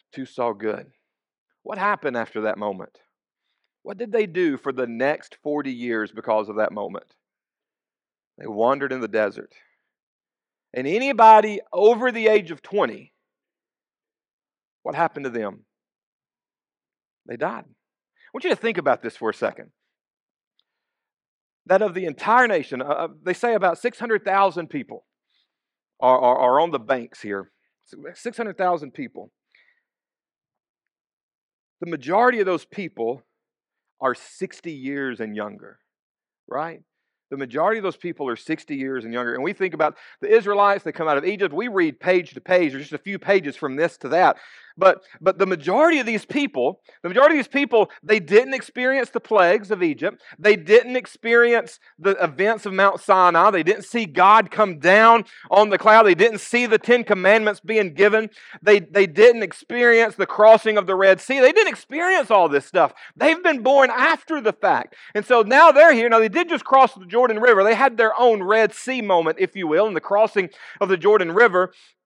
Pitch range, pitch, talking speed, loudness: 170-240 Hz, 205 Hz, 175 wpm, -19 LUFS